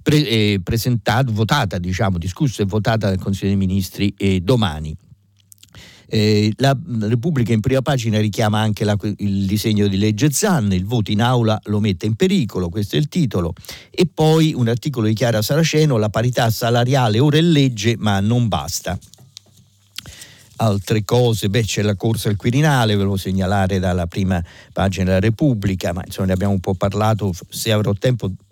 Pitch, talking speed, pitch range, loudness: 110 Hz, 175 wpm, 100-120 Hz, -18 LUFS